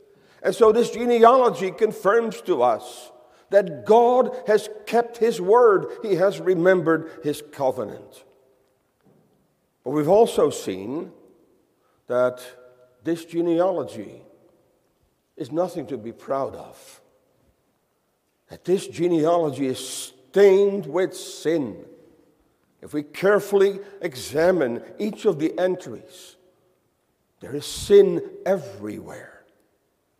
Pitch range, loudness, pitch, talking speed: 150-220 Hz, -21 LUFS, 185 Hz, 100 wpm